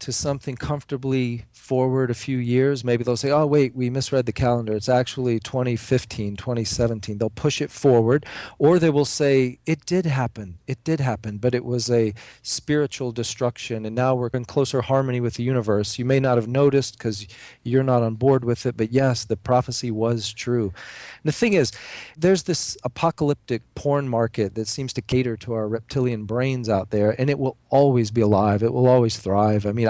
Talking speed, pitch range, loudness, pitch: 195 wpm, 115-135 Hz, -22 LUFS, 125 Hz